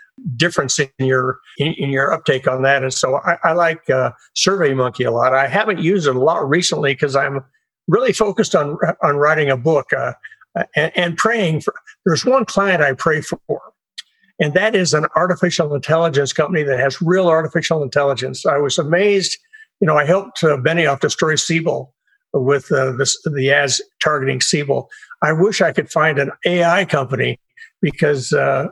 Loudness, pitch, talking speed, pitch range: -17 LUFS, 160 Hz, 180 wpm, 140-185 Hz